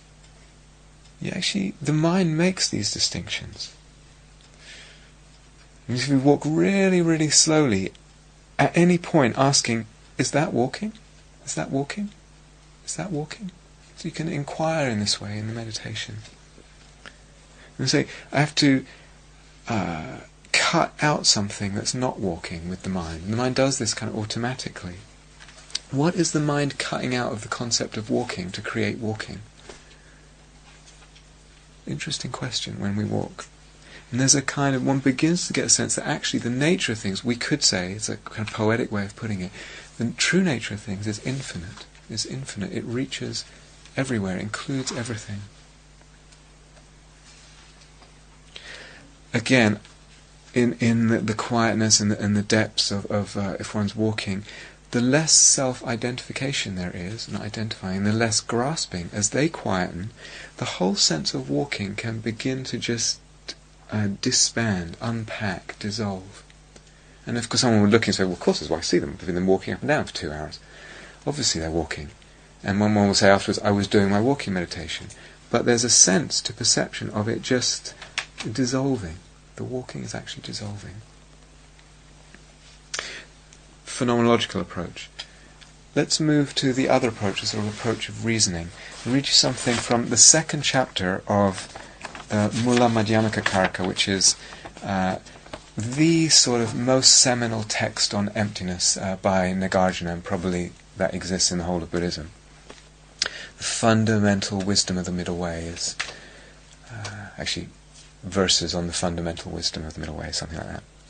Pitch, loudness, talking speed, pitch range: 115 Hz, -23 LUFS, 160 wpm, 100-135 Hz